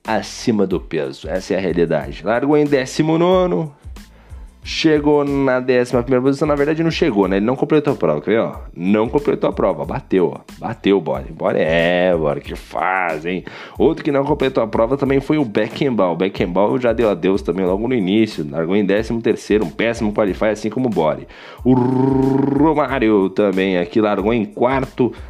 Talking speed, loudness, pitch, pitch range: 175 wpm, -17 LUFS, 125 Hz, 100-140 Hz